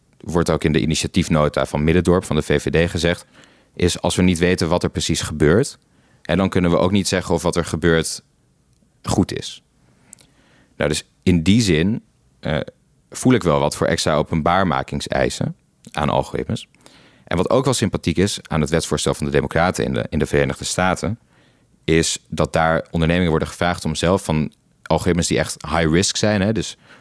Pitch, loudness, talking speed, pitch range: 85 Hz, -19 LUFS, 185 wpm, 75-90 Hz